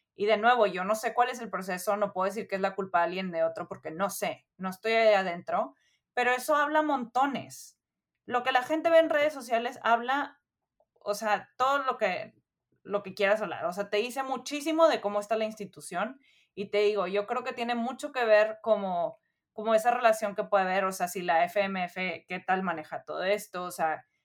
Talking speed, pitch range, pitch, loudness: 220 wpm, 190-245 Hz, 210 Hz, -29 LUFS